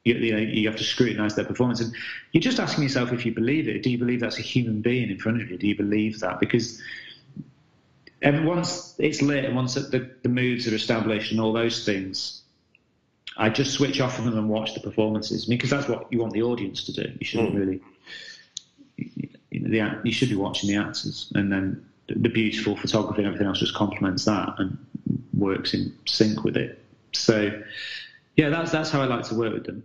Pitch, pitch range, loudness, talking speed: 115 Hz, 105-130 Hz, -25 LUFS, 215 wpm